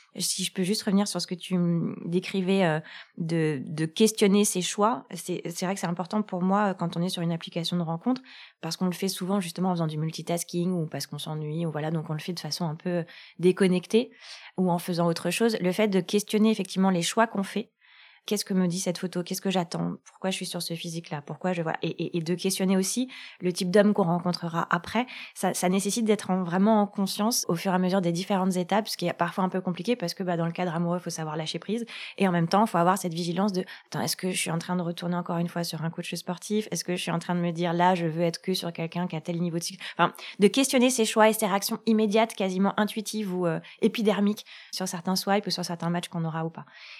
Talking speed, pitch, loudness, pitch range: 270 wpm, 185 Hz, -27 LUFS, 170-200 Hz